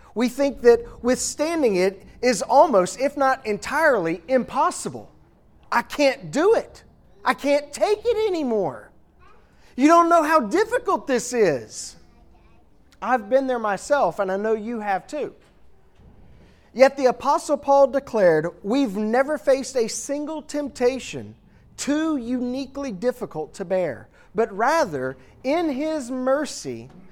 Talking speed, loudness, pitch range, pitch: 130 wpm, -22 LUFS, 195-285 Hz, 250 Hz